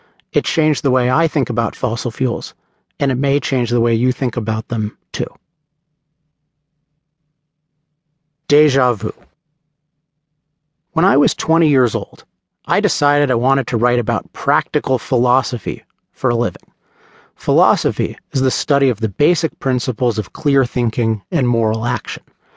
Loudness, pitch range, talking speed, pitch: -17 LUFS, 125-155 Hz, 145 wpm, 140 Hz